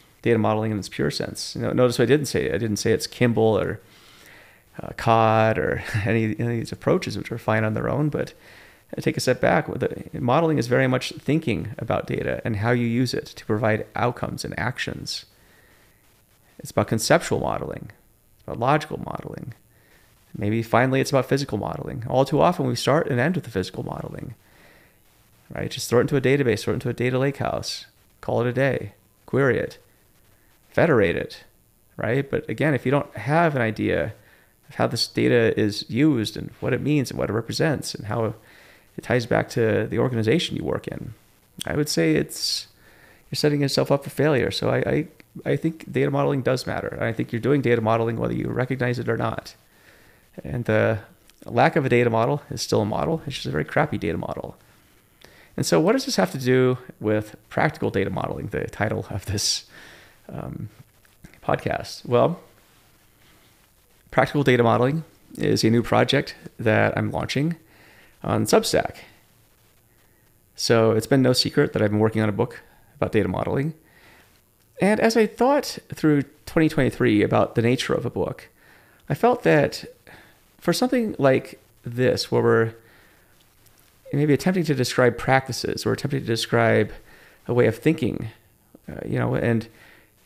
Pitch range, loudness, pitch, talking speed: 110-145 Hz, -23 LUFS, 120 Hz, 180 wpm